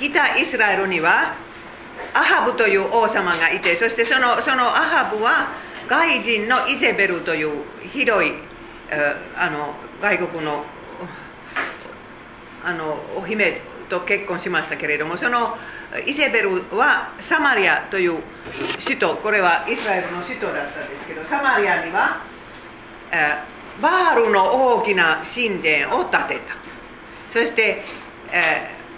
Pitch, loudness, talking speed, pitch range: 205 Hz, -19 LUFS, 260 characters per minute, 165-240 Hz